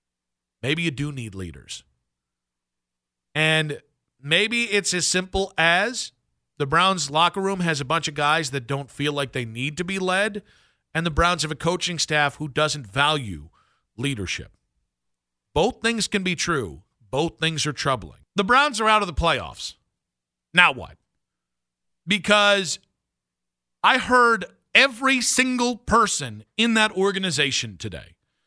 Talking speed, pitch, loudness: 145 wpm, 150 Hz, -21 LUFS